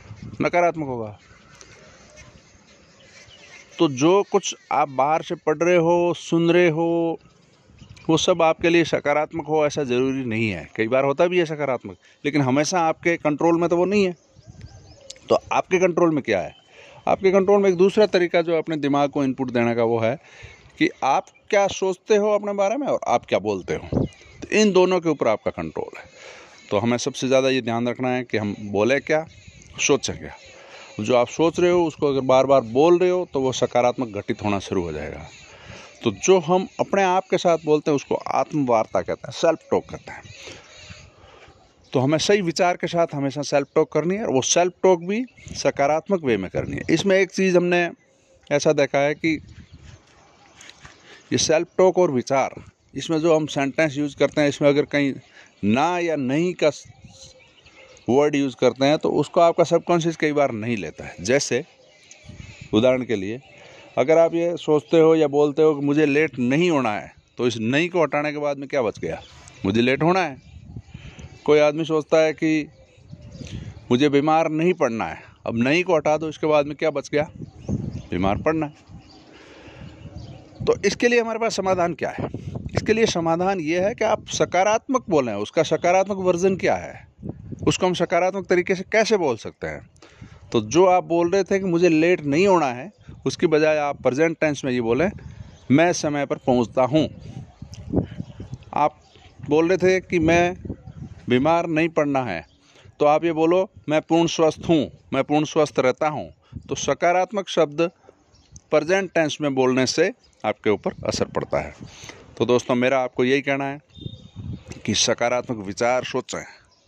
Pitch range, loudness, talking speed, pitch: 130-175 Hz, -21 LUFS, 180 wpm, 155 Hz